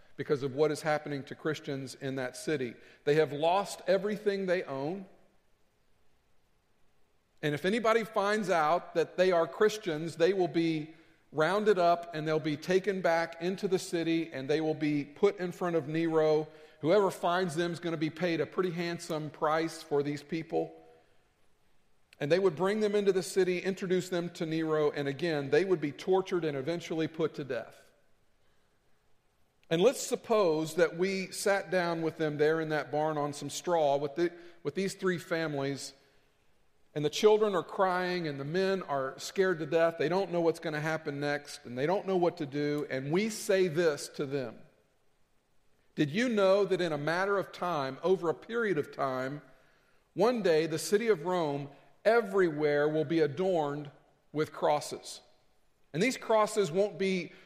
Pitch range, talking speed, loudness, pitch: 150-185 Hz, 180 wpm, -31 LUFS, 165 Hz